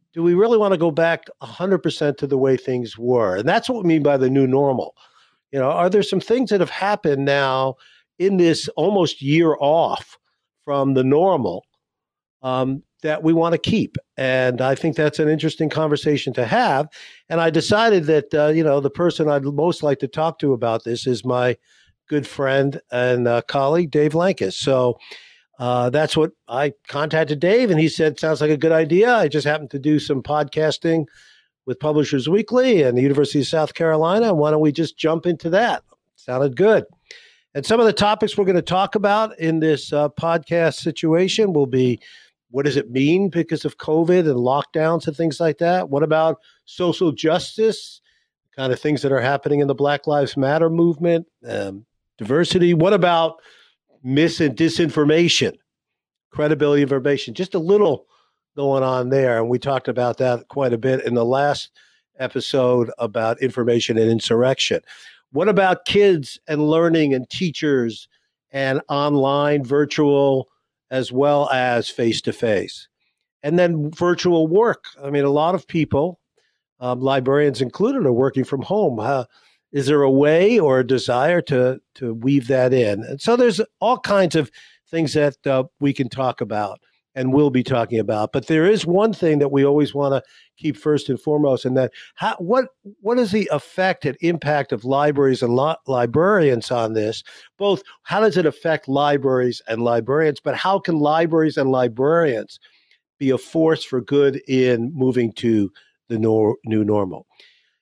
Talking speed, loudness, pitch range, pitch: 180 wpm, -19 LUFS, 130-165 Hz, 145 Hz